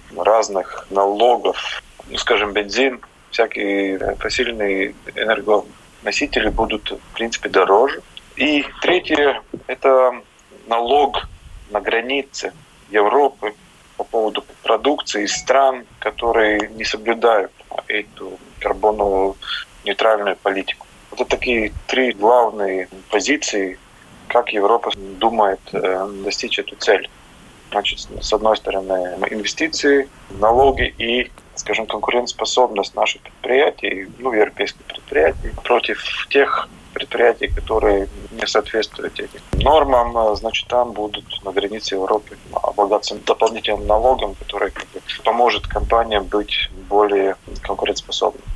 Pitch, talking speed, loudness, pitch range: 105 Hz, 100 wpm, -18 LUFS, 100-120 Hz